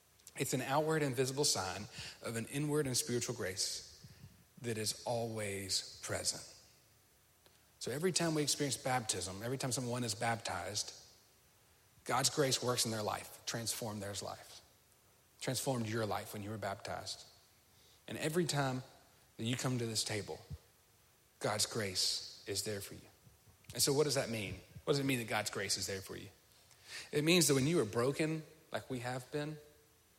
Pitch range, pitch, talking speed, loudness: 105-140 Hz, 120 Hz, 170 wpm, -37 LUFS